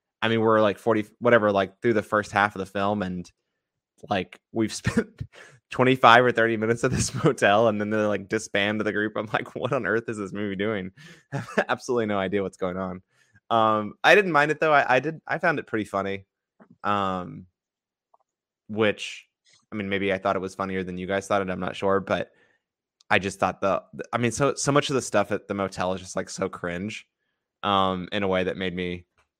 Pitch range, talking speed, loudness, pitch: 95-115 Hz, 220 wpm, -24 LUFS, 105 Hz